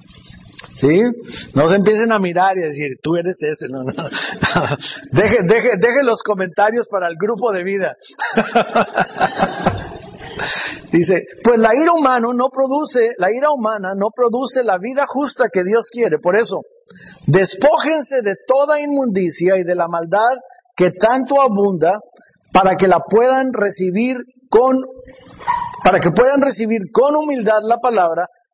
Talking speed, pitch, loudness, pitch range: 145 wpm, 225 Hz, -16 LUFS, 185-255 Hz